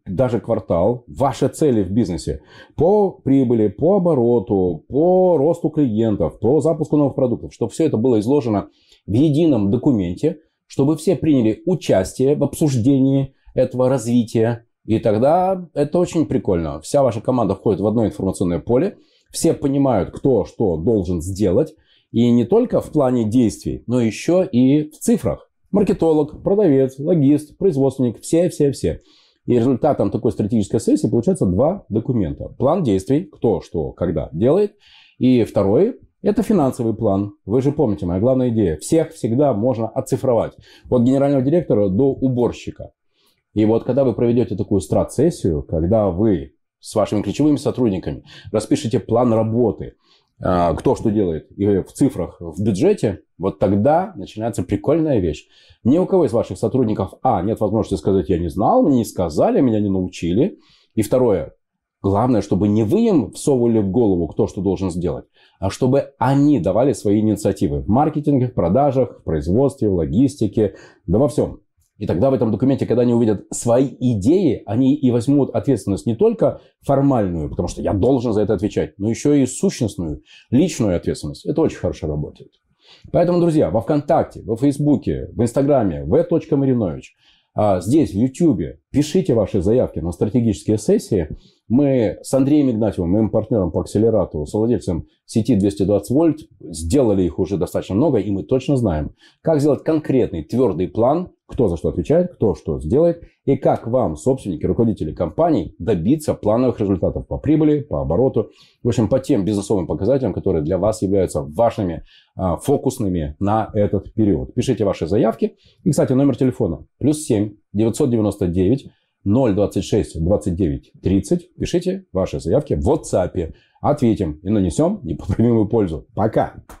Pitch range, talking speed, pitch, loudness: 100-140 Hz, 150 wpm, 115 Hz, -18 LUFS